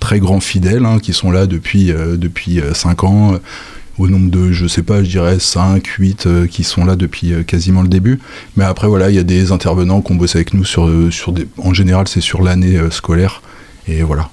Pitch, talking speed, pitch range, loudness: 90 Hz, 230 wpm, 85-95 Hz, -13 LUFS